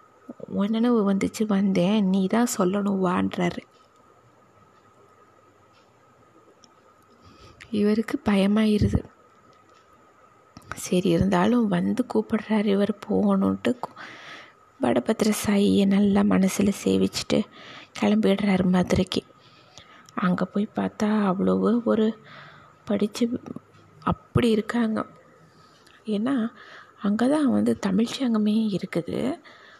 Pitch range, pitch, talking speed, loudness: 190-235 Hz, 210 Hz, 75 wpm, -24 LUFS